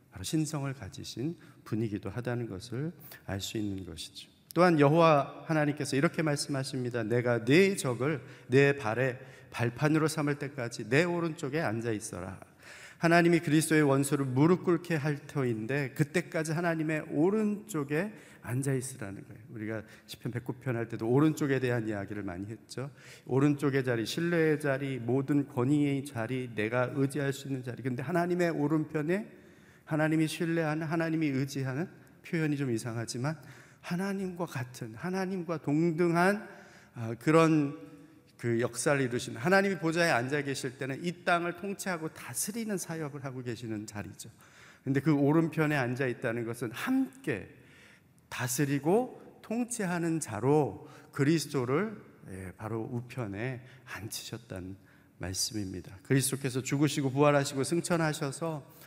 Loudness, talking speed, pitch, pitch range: -31 LUFS, 330 characters per minute, 140 Hz, 125-160 Hz